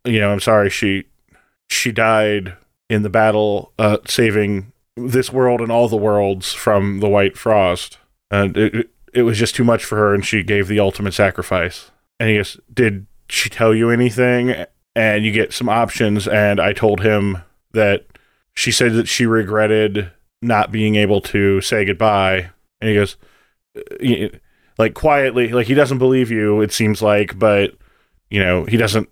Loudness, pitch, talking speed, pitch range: -16 LUFS, 110 Hz, 175 wpm, 100-115 Hz